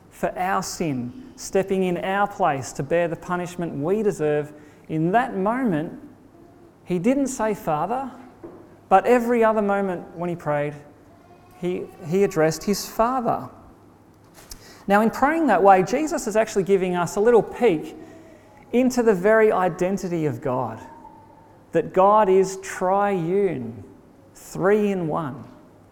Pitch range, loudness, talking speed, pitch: 165-215 Hz, -22 LUFS, 135 wpm, 190 Hz